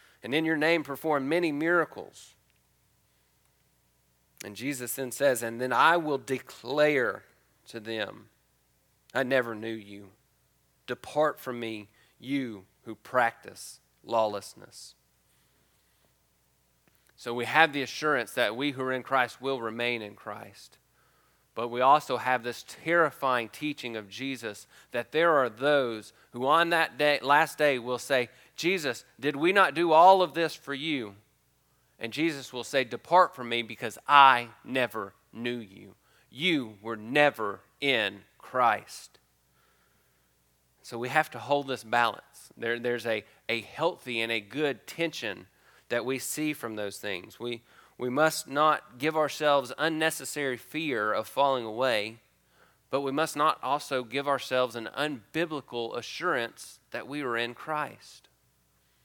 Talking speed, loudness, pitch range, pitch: 140 wpm, -28 LUFS, 110-145 Hz, 125 Hz